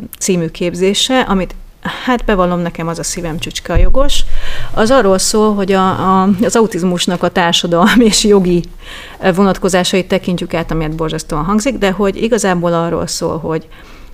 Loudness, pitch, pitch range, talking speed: -13 LUFS, 185 Hz, 170-205 Hz, 155 wpm